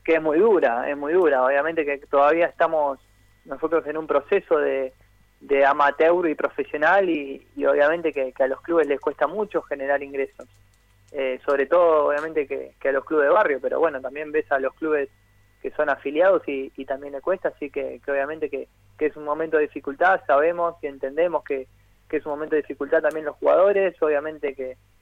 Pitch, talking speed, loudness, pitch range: 145 Hz, 205 wpm, -22 LUFS, 135-160 Hz